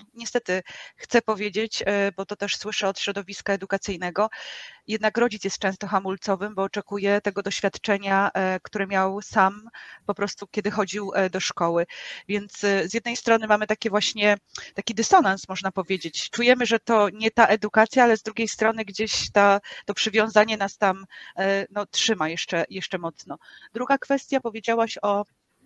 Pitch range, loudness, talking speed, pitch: 195-220 Hz, -24 LUFS, 150 wpm, 205 Hz